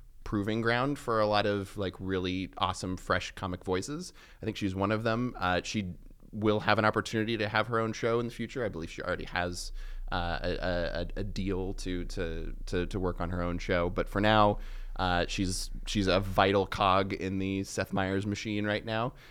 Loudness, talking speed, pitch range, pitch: -31 LUFS, 210 wpm, 90-110 Hz, 100 Hz